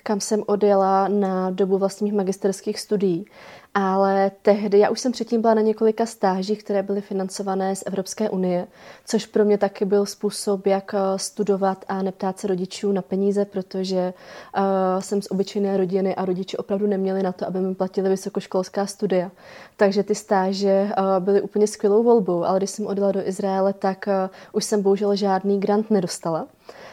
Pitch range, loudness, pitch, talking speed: 190-205 Hz, -22 LUFS, 195 Hz, 170 wpm